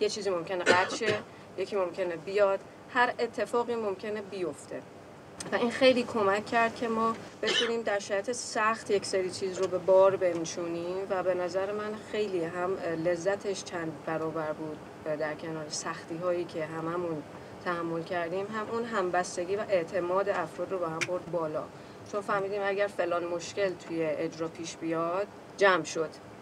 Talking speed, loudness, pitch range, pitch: 155 wpm, -30 LUFS, 170-205 Hz, 185 Hz